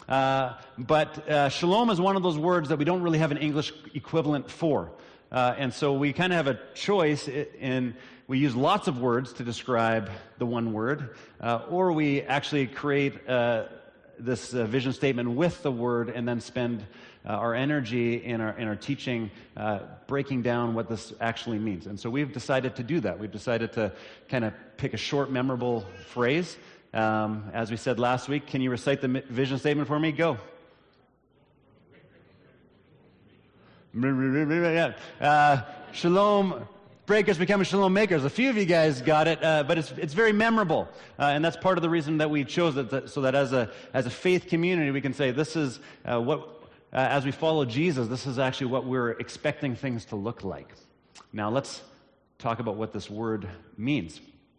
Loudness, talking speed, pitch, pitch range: -27 LUFS, 190 wpm, 135 Hz, 120-155 Hz